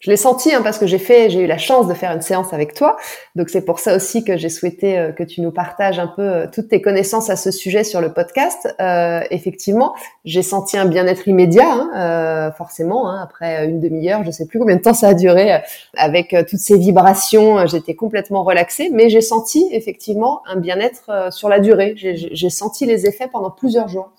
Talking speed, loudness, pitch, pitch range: 230 wpm, -15 LUFS, 190 Hz, 175-215 Hz